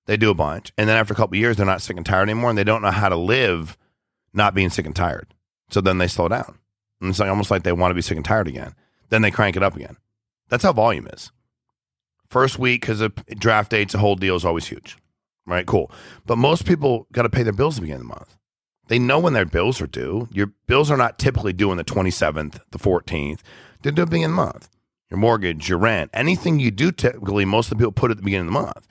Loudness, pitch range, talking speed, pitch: -20 LUFS, 95-115 Hz, 270 wpm, 105 Hz